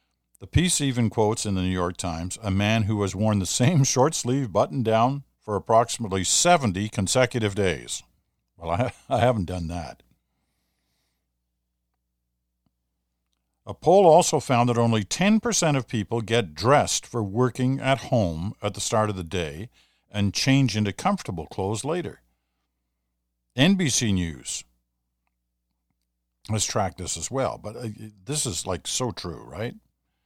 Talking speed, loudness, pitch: 145 wpm, -23 LUFS, 100 Hz